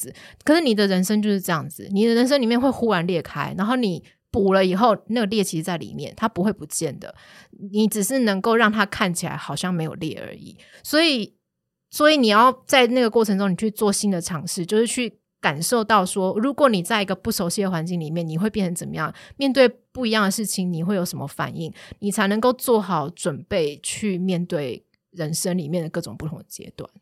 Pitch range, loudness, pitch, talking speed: 175-225 Hz, -21 LUFS, 200 Hz, 320 characters per minute